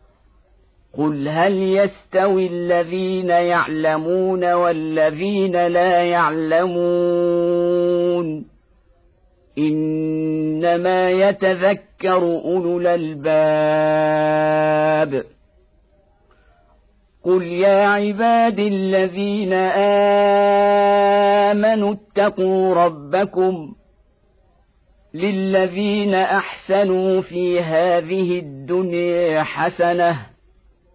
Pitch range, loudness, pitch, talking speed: 155-190 Hz, -18 LUFS, 175 Hz, 50 wpm